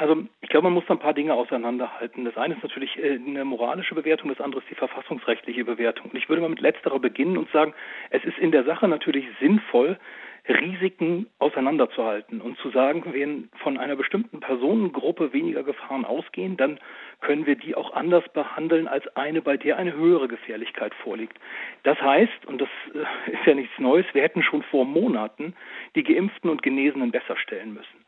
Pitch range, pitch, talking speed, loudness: 135-195 Hz, 160 Hz, 185 wpm, -24 LUFS